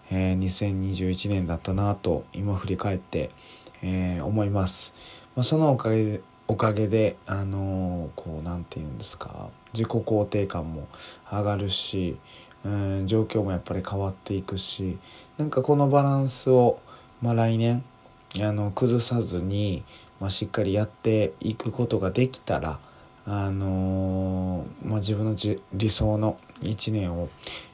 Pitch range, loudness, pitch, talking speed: 95-110 Hz, -27 LUFS, 100 Hz, 230 characters per minute